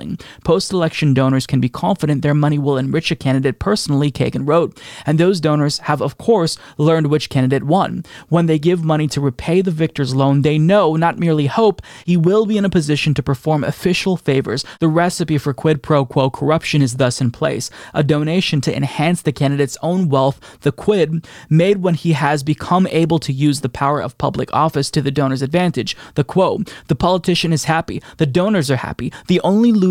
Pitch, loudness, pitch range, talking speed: 155 Hz, -17 LUFS, 140-175 Hz, 200 wpm